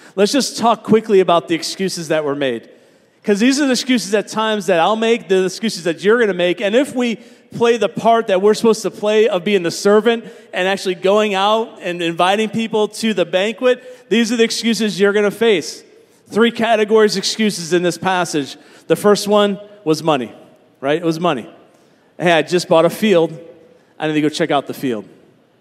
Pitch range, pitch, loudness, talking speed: 170-225 Hz, 205 Hz, -16 LUFS, 205 wpm